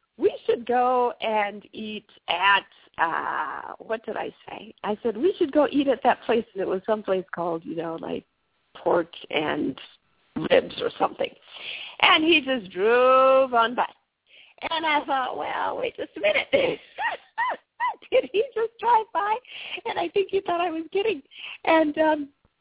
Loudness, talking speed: -24 LUFS, 165 wpm